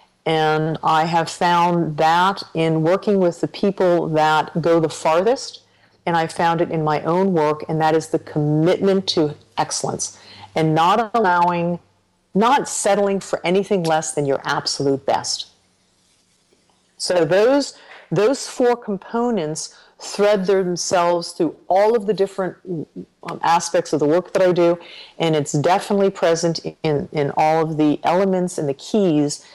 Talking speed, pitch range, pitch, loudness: 150 wpm, 155-190 Hz, 170 Hz, -19 LUFS